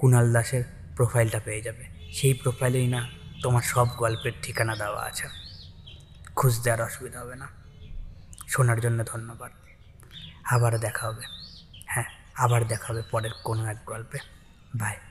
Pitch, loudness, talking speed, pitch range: 115 Hz, -27 LUFS, 135 wpm, 105-120 Hz